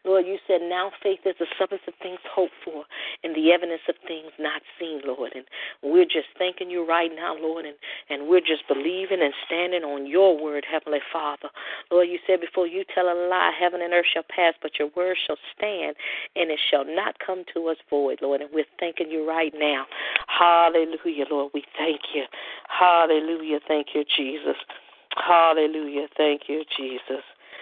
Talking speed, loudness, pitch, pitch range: 185 wpm, -24 LUFS, 165 Hz, 150-180 Hz